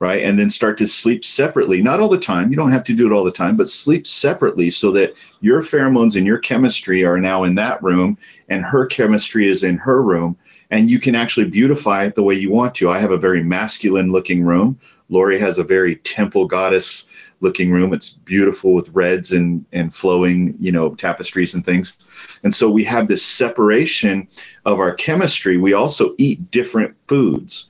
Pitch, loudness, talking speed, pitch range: 95 Hz, -16 LUFS, 205 wpm, 90-110 Hz